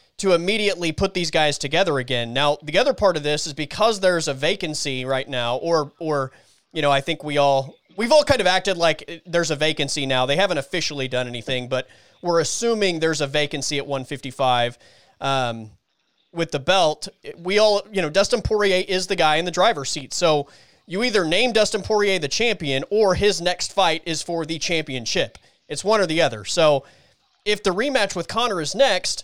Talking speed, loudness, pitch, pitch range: 200 wpm, -21 LUFS, 160 Hz, 140-190 Hz